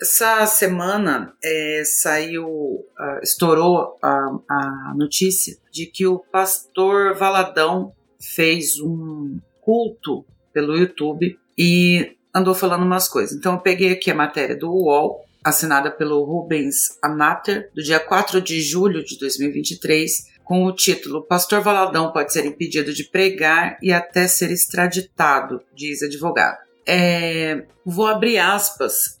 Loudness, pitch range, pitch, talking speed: -18 LUFS, 155-185 Hz, 170 Hz, 125 wpm